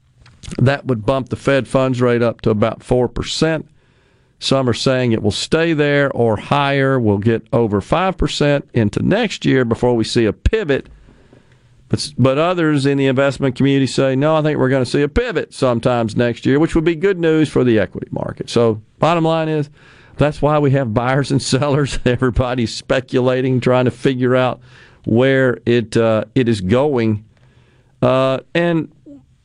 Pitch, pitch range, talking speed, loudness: 130 Hz, 120-140 Hz, 180 wpm, -16 LUFS